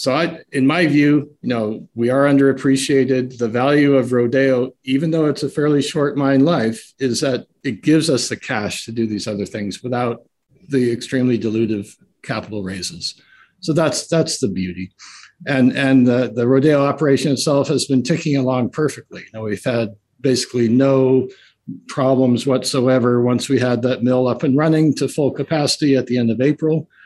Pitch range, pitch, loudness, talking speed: 120-145 Hz, 130 Hz, -17 LUFS, 180 wpm